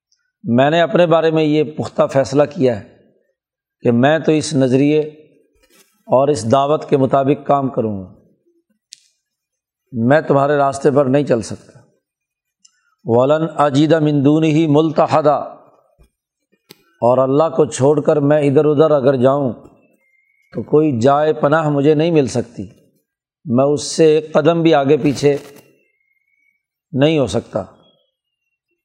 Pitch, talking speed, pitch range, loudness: 150 Hz, 135 wpm, 140-160 Hz, -15 LUFS